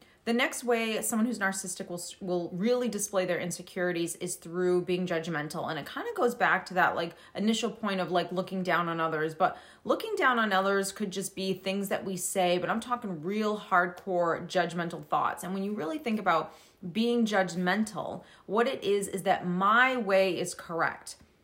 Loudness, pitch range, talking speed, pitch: -29 LUFS, 175-210 Hz, 195 wpm, 190 Hz